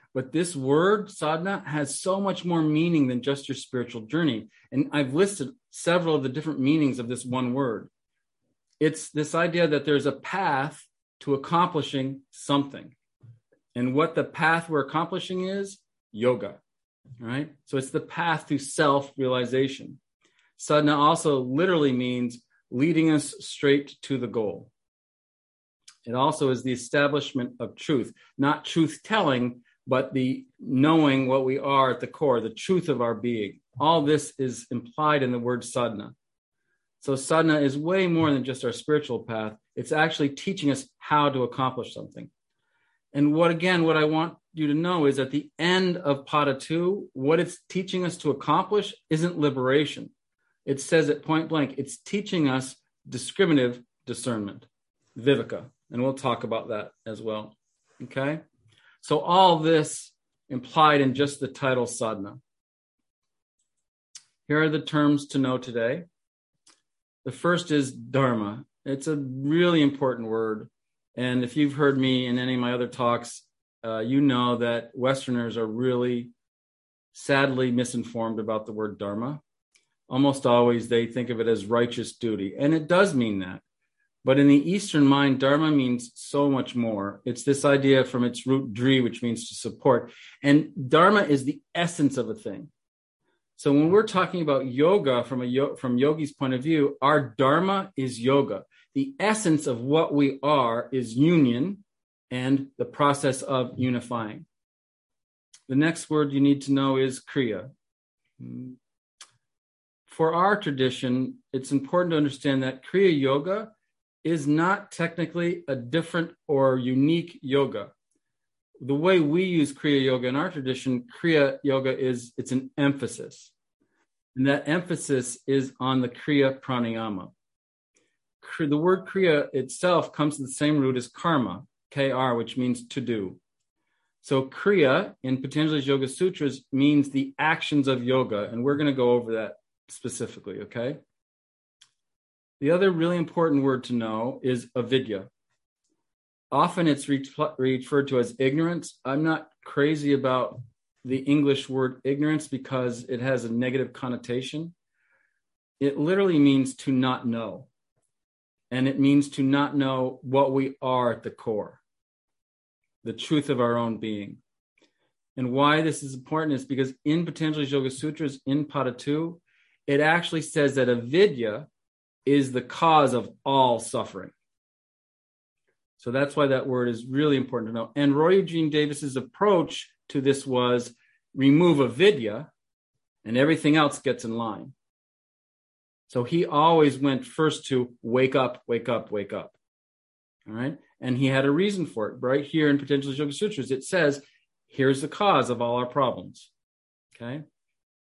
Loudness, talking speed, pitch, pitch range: -25 LUFS, 155 wpm, 140 Hz, 125-155 Hz